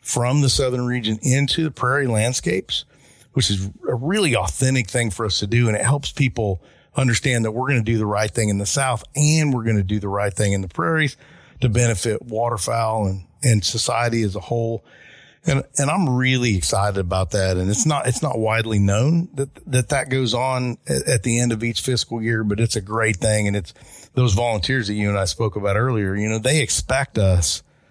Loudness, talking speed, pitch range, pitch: -20 LUFS, 215 wpm, 105-130 Hz, 115 Hz